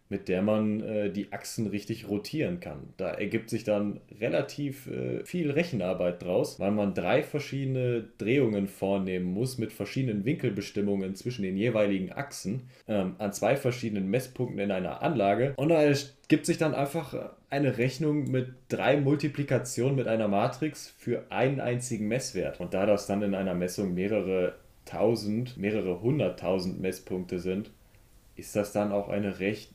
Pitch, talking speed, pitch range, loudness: 110 Hz, 155 wpm, 100-130 Hz, -30 LUFS